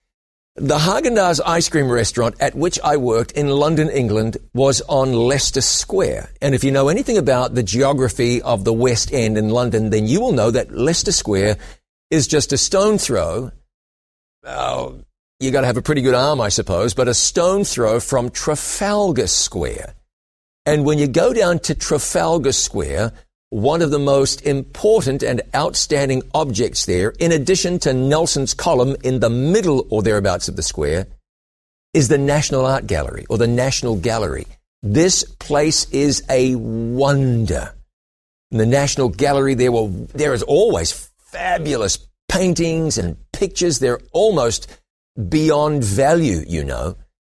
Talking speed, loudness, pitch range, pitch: 155 wpm, -17 LUFS, 115-150 Hz, 130 Hz